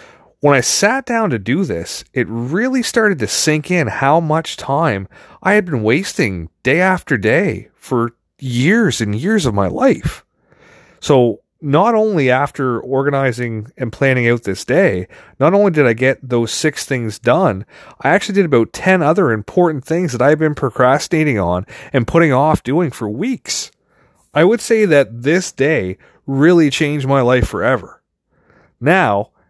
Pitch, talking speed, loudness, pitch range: 145 Hz, 165 wpm, -15 LUFS, 125-180 Hz